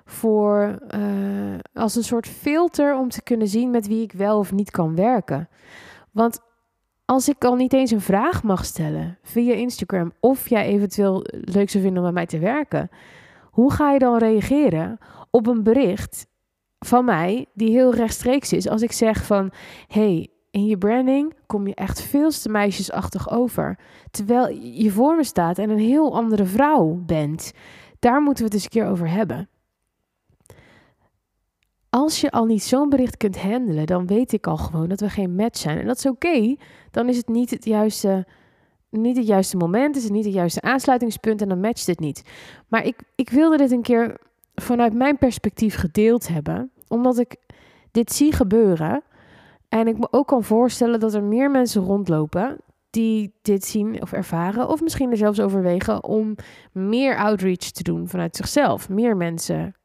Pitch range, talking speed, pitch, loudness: 195-245 Hz, 180 wpm, 220 Hz, -20 LUFS